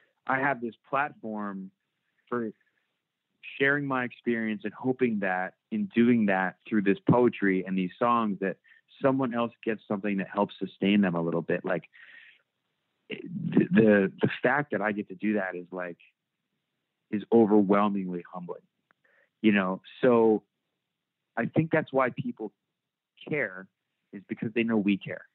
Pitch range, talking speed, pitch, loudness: 100-120 Hz, 150 wpm, 105 Hz, -27 LUFS